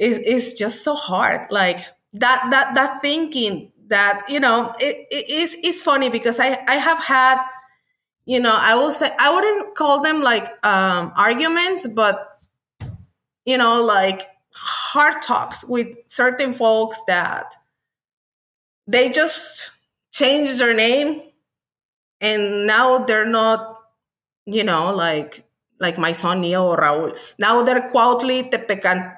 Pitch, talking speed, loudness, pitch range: 235 Hz, 135 wpm, -17 LUFS, 205-270 Hz